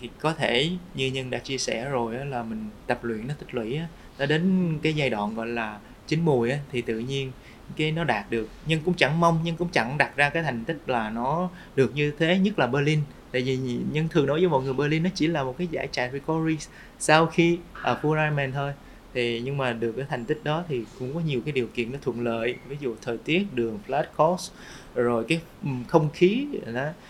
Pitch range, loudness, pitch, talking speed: 120-160 Hz, -26 LUFS, 140 Hz, 235 wpm